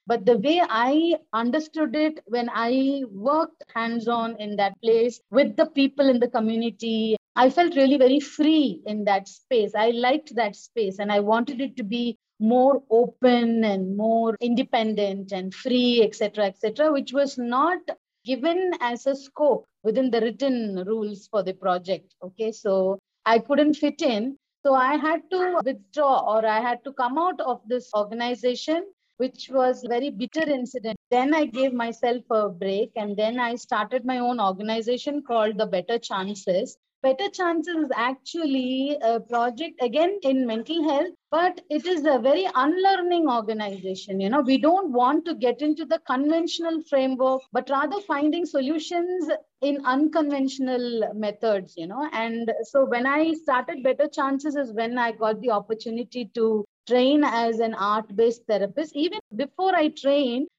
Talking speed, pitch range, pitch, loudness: 165 wpm, 225-290 Hz, 250 Hz, -24 LUFS